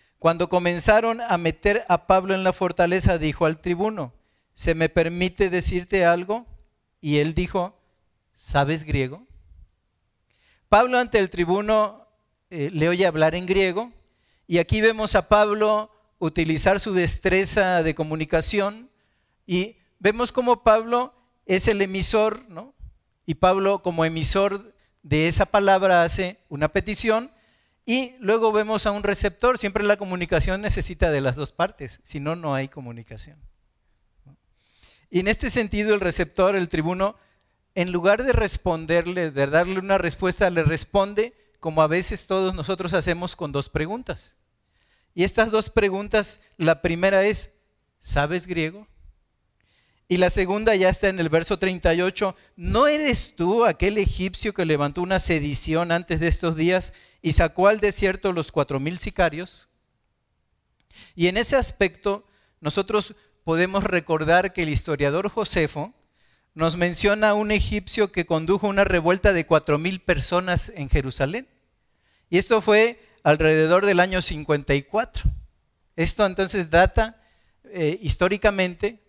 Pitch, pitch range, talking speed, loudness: 180 Hz, 160-205 Hz, 140 wpm, -22 LUFS